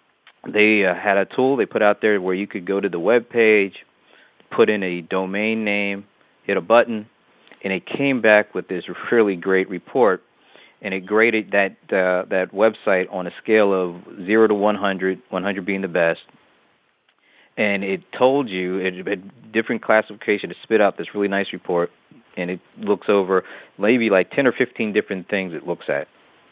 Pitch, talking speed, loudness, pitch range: 100 Hz, 185 wpm, -20 LUFS, 95-105 Hz